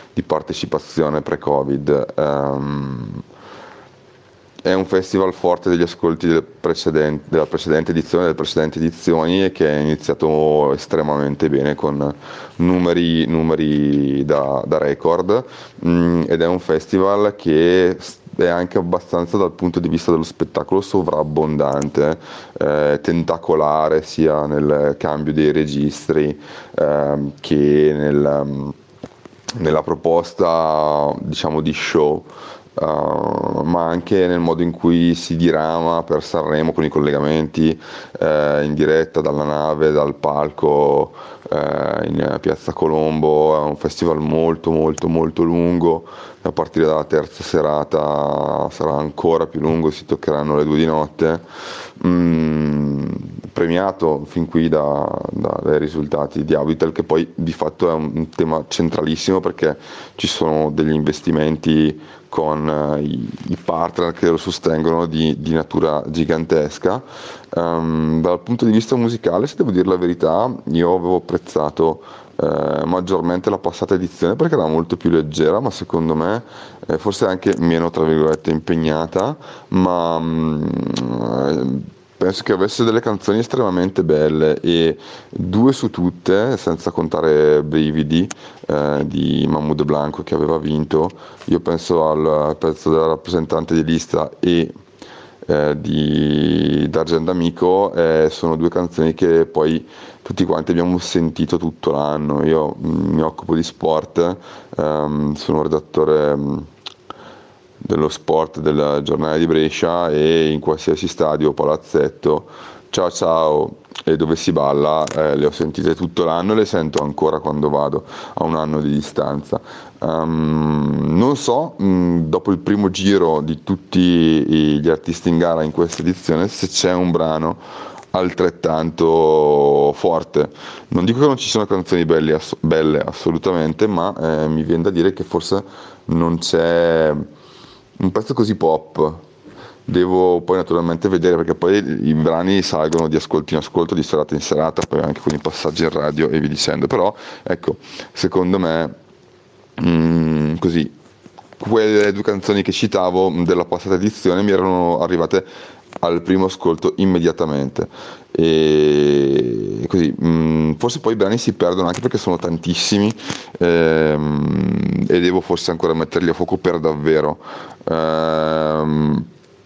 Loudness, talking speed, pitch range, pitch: -17 LUFS, 135 wpm, 75-85 Hz, 80 Hz